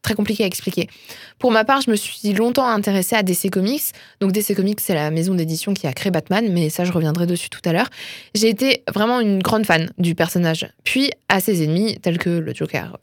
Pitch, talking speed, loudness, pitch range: 195 Hz, 230 wpm, -19 LUFS, 175-220 Hz